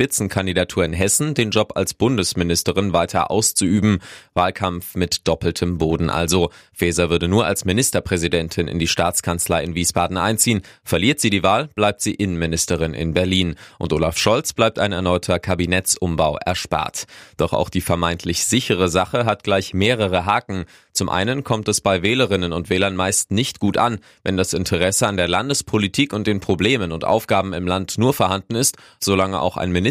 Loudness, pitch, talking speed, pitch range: -19 LUFS, 95 Hz, 170 wpm, 90-105 Hz